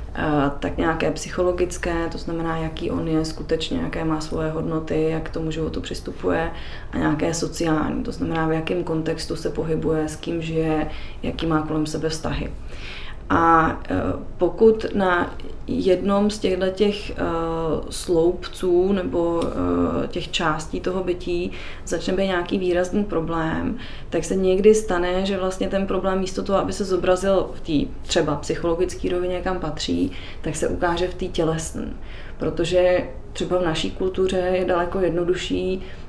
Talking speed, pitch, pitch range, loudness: 145 wpm, 165 Hz, 155-185 Hz, -23 LUFS